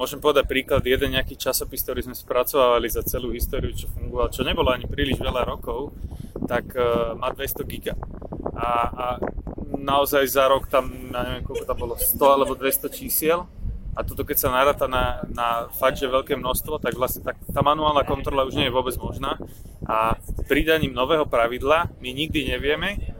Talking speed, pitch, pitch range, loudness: 180 wpm, 130 Hz, 120-140 Hz, -23 LUFS